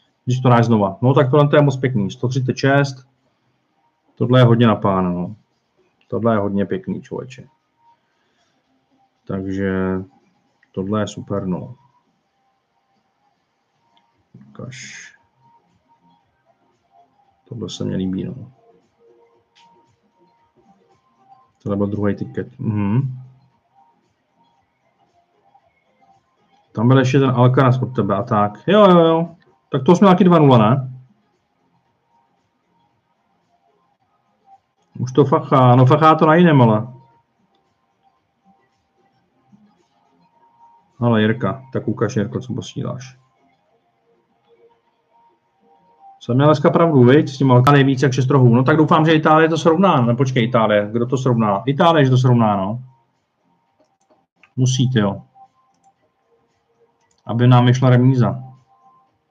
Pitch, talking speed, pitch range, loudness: 130 Hz, 105 wpm, 115-155 Hz, -16 LUFS